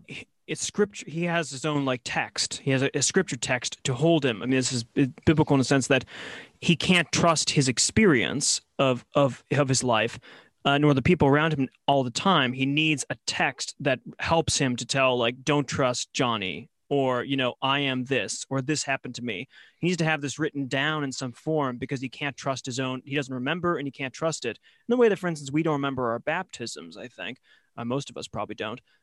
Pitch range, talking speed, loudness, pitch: 130-155 Hz, 230 wpm, -25 LUFS, 140 Hz